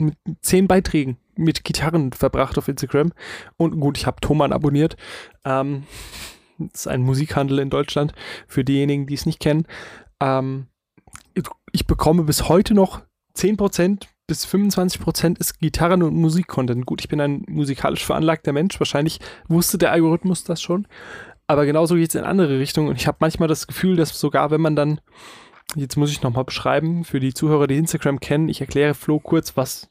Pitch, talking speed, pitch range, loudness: 150 Hz, 175 wpm, 140-165 Hz, -20 LUFS